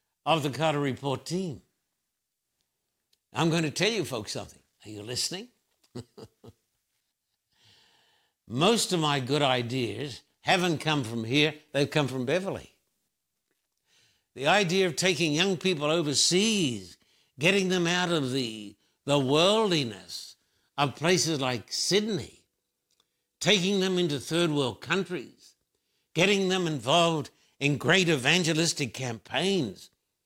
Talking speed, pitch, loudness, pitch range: 115 wpm, 155 Hz, -26 LUFS, 130-180 Hz